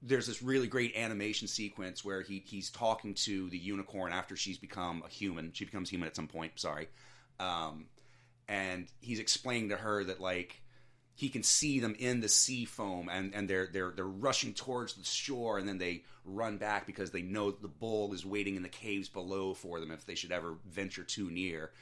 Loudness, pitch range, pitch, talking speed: -36 LUFS, 95-115 Hz, 100 Hz, 205 wpm